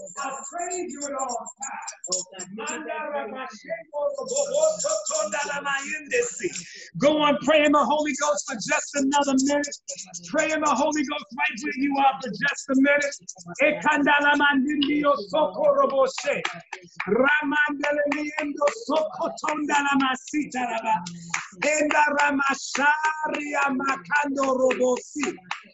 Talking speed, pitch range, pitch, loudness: 90 wpm, 270-300 Hz, 290 Hz, -24 LUFS